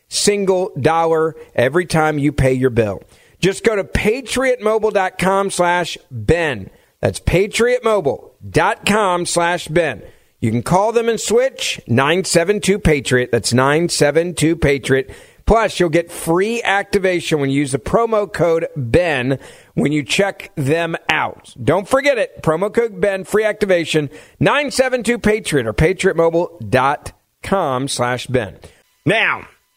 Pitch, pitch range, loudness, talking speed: 170 Hz, 145-205 Hz, -17 LUFS, 125 wpm